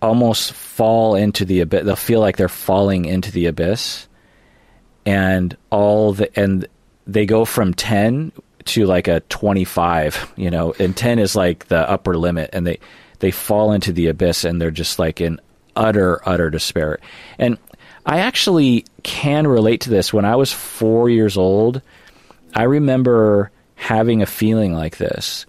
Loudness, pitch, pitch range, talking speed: -17 LUFS, 100 Hz, 90-110 Hz, 165 wpm